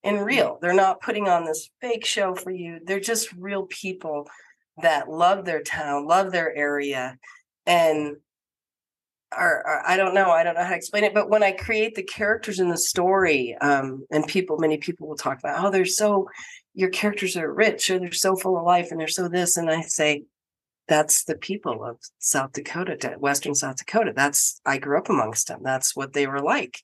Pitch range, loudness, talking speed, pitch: 150-200 Hz, -23 LUFS, 200 wpm, 175 Hz